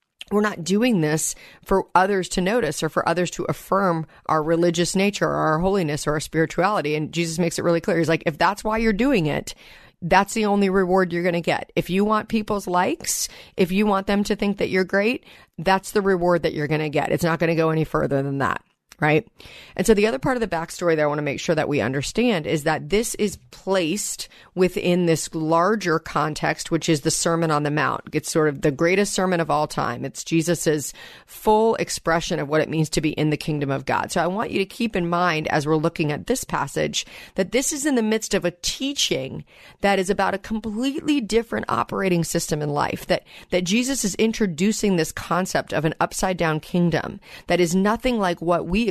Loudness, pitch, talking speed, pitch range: -22 LUFS, 175 Hz, 225 wpm, 160-200 Hz